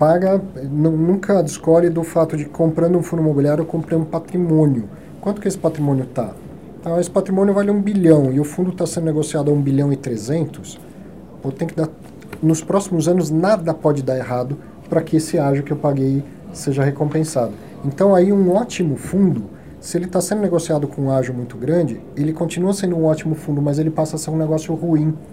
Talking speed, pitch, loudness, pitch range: 200 wpm, 160 Hz, -18 LUFS, 145-175 Hz